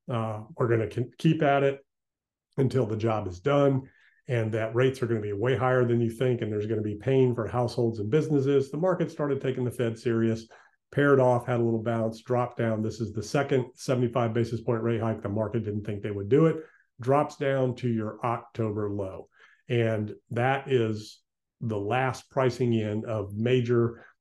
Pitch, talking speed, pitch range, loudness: 120 Hz, 205 wpm, 110-130 Hz, -27 LUFS